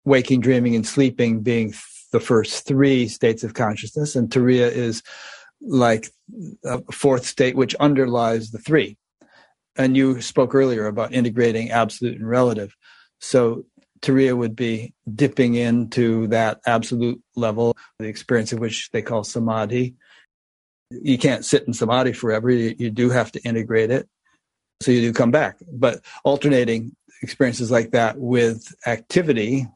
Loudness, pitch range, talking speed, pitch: -20 LUFS, 115-125 Hz, 145 wpm, 120 Hz